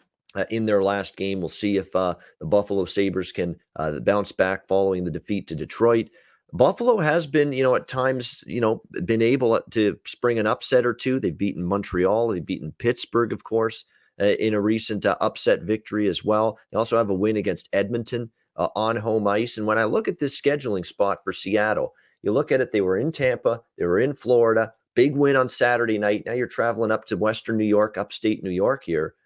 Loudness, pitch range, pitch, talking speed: -23 LUFS, 100-120 Hz, 110 Hz, 215 wpm